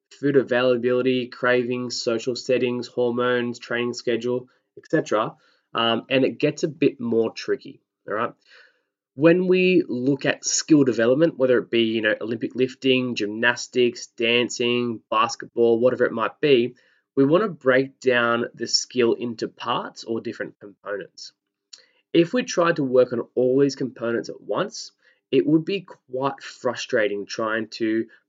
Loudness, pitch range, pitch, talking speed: -22 LUFS, 120-135 Hz, 125 Hz, 145 wpm